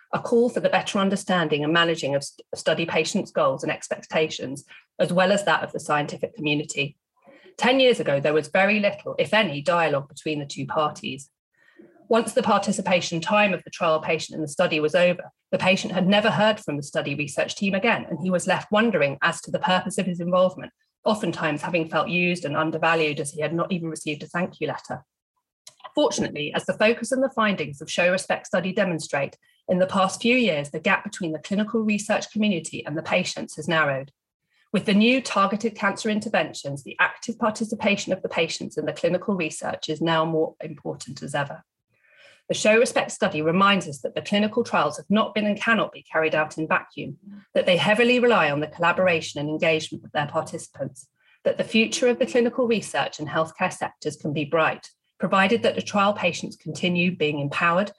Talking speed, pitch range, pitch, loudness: 200 wpm, 155-210 Hz, 180 Hz, -23 LUFS